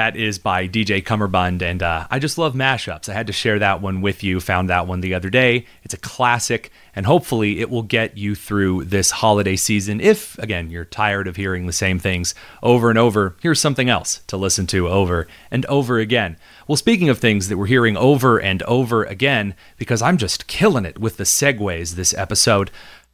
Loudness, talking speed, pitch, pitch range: -18 LUFS, 210 wpm, 105 Hz, 95-120 Hz